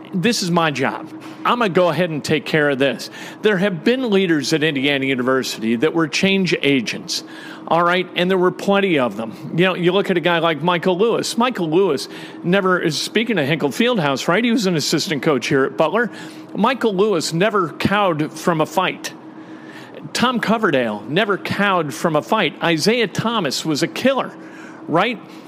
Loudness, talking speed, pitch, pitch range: -18 LUFS, 185 wpm, 180 Hz, 160-205 Hz